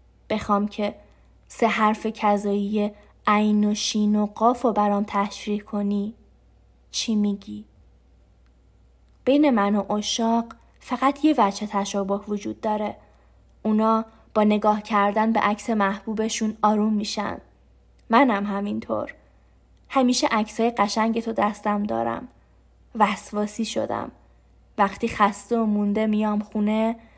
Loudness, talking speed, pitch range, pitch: -23 LUFS, 115 wpm, 205-220 Hz, 210 Hz